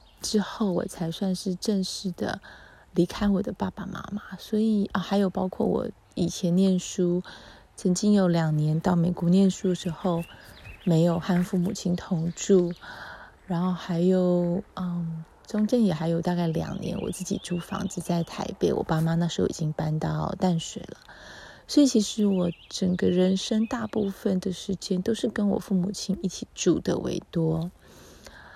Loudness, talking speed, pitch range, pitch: -26 LUFS, 240 characters per minute, 175-200 Hz, 185 Hz